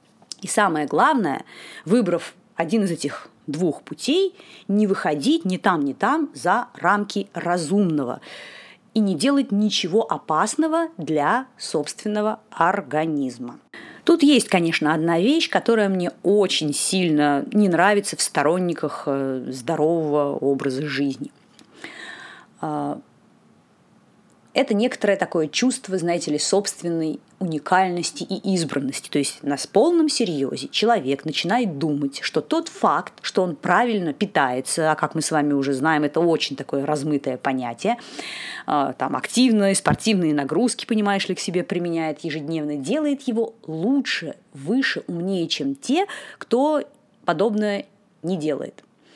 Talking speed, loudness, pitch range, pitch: 120 wpm, -22 LUFS, 150-225 Hz, 180 Hz